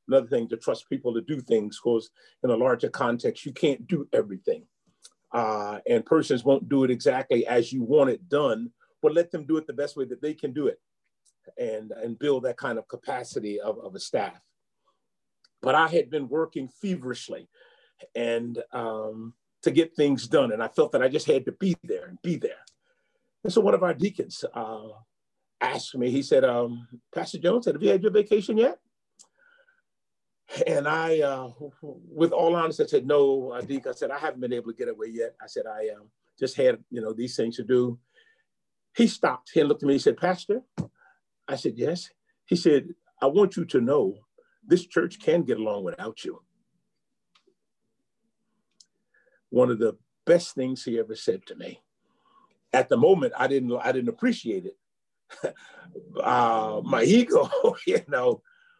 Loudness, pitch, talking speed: -26 LUFS, 165 Hz, 185 wpm